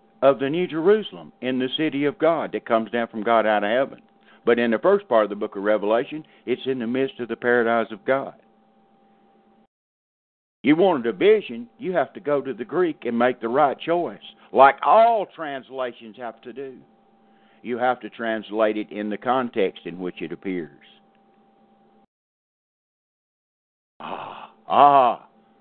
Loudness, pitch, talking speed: -22 LUFS, 130 Hz, 170 wpm